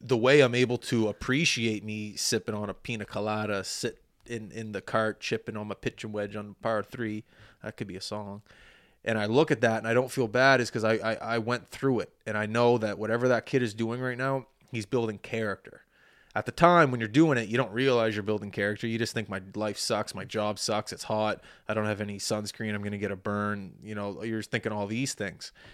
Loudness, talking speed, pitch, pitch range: -29 LUFS, 245 wpm, 110 Hz, 105-120 Hz